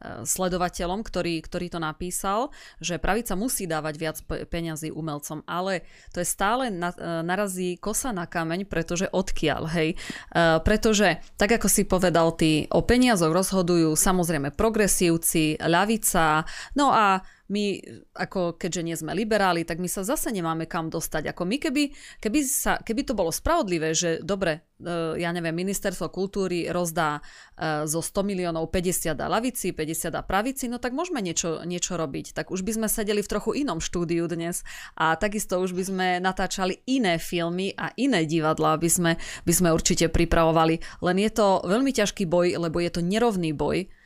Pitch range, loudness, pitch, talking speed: 165-200 Hz, -25 LUFS, 180 Hz, 160 wpm